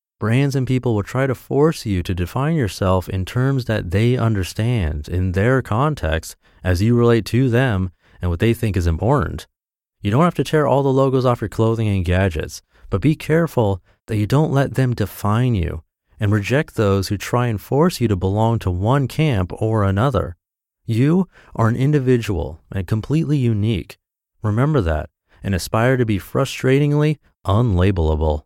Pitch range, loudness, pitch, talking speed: 95-130 Hz, -19 LUFS, 110 Hz, 175 wpm